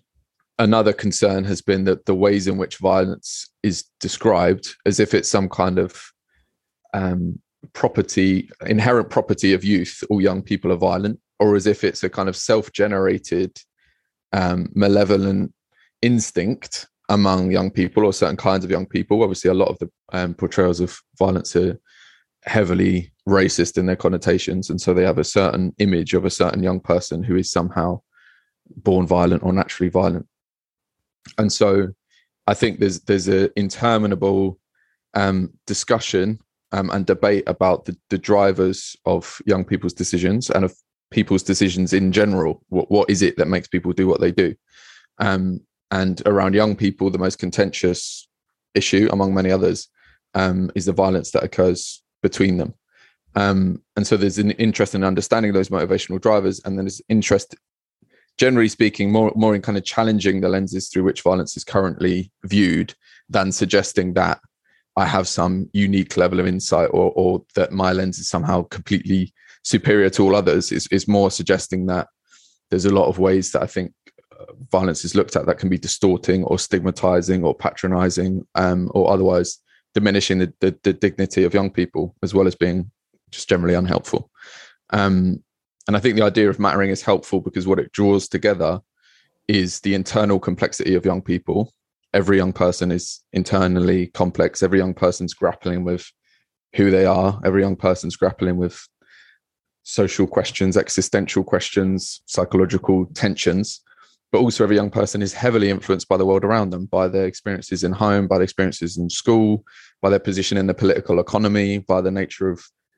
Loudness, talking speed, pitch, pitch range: -19 LUFS, 170 wpm, 95 Hz, 90-100 Hz